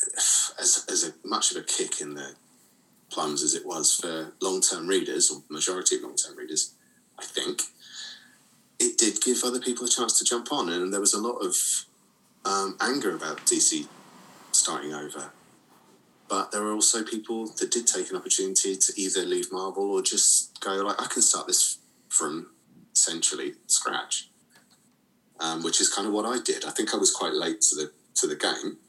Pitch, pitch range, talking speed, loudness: 365 Hz, 310-380 Hz, 185 wpm, -24 LUFS